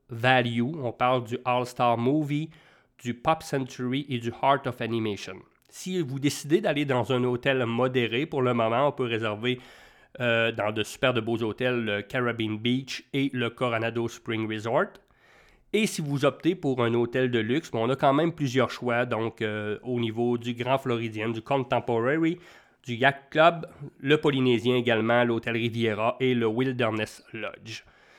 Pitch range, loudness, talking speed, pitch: 115-135 Hz, -26 LUFS, 170 wpm, 125 Hz